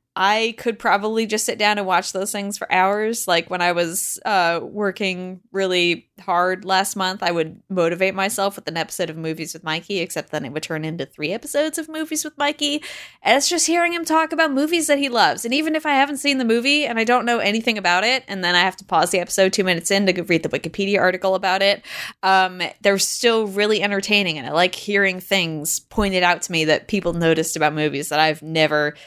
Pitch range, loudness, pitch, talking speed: 170-225 Hz, -19 LUFS, 190 Hz, 230 wpm